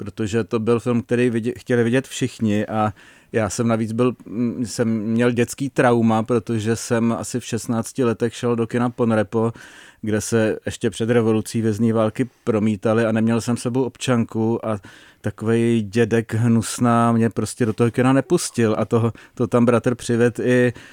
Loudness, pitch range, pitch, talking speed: -20 LUFS, 110-120 Hz, 115 Hz, 165 wpm